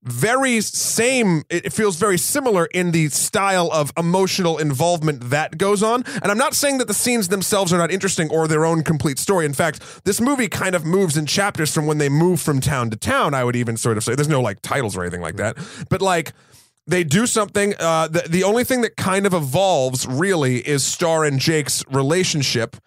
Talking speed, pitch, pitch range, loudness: 215 wpm, 165 Hz, 145-195 Hz, -19 LUFS